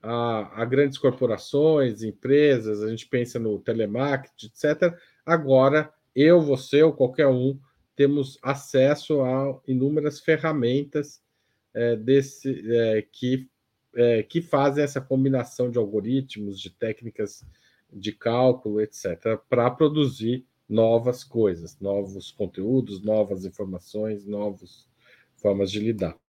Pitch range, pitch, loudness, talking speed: 110-140 Hz, 125 Hz, -24 LUFS, 115 wpm